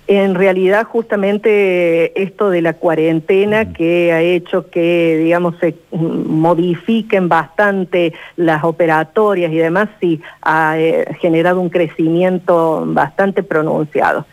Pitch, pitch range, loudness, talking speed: 175 Hz, 165-195 Hz, -14 LUFS, 110 wpm